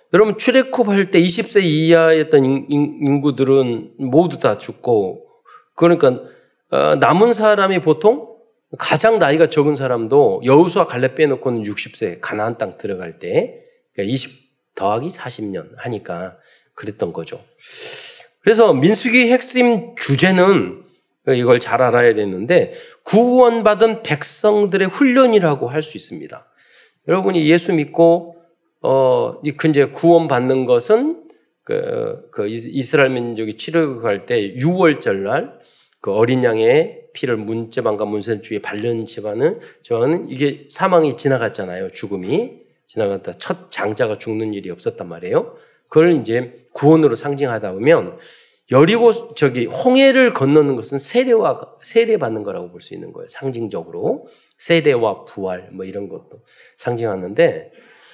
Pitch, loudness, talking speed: 170 Hz, -16 LUFS, 285 characters per minute